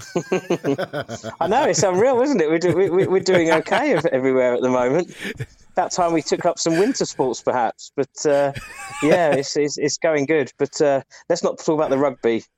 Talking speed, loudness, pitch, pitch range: 195 wpm, -20 LUFS, 160 Hz, 140-175 Hz